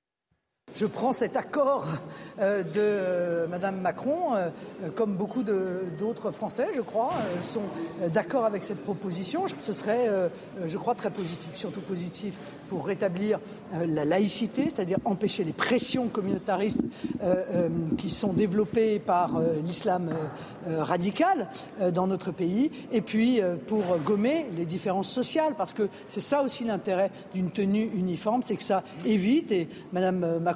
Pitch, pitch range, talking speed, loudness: 200 Hz, 180-220 Hz, 135 wpm, -28 LUFS